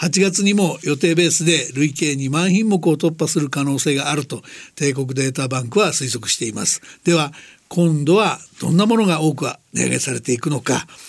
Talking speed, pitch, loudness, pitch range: 355 characters per minute, 155 Hz, -18 LUFS, 135-170 Hz